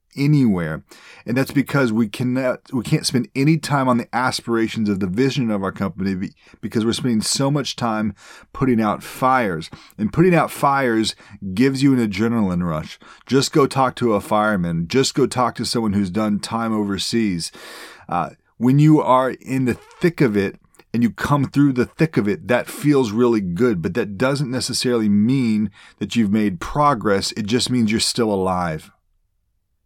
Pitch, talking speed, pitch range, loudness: 120 Hz, 180 wpm, 105-135 Hz, -19 LUFS